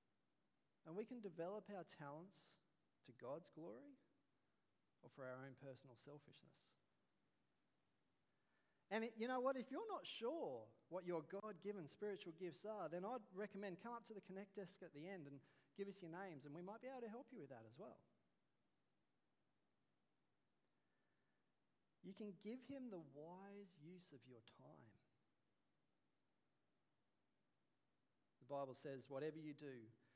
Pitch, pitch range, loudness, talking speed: 180 Hz, 145-205 Hz, -54 LUFS, 150 wpm